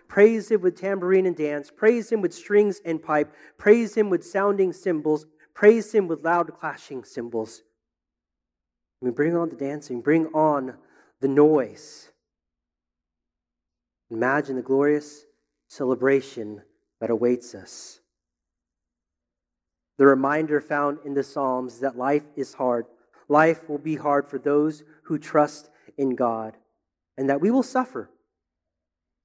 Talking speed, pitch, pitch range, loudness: 130 wpm, 140 Hz, 110-155 Hz, -23 LUFS